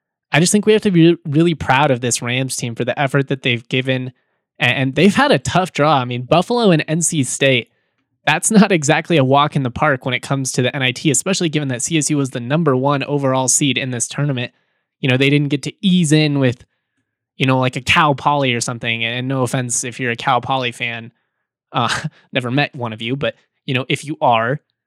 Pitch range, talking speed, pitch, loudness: 125-155 Hz, 230 wpm, 135 Hz, -16 LUFS